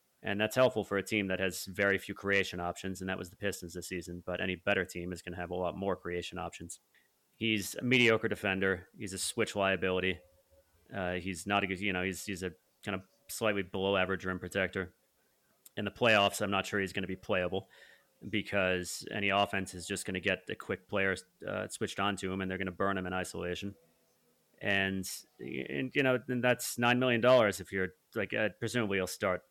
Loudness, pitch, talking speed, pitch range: -33 LUFS, 95 Hz, 220 wpm, 90-100 Hz